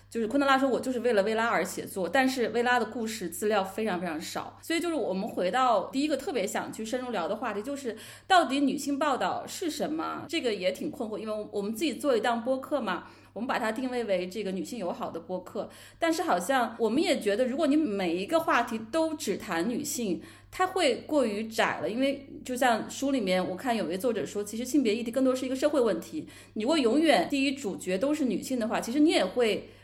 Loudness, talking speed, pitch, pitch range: -29 LUFS, 350 characters per minute, 245 Hz, 215-285 Hz